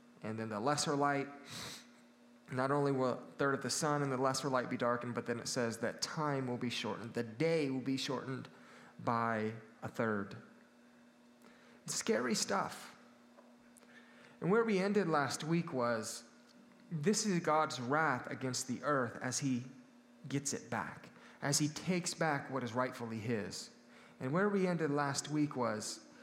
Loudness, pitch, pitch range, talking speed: -36 LUFS, 130 Hz, 120-150 Hz, 165 wpm